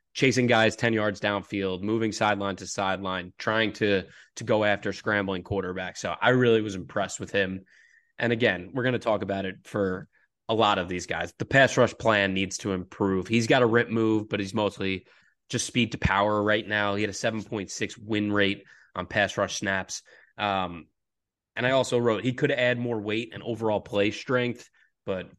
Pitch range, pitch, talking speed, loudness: 95-115 Hz, 105 Hz, 195 wpm, -26 LUFS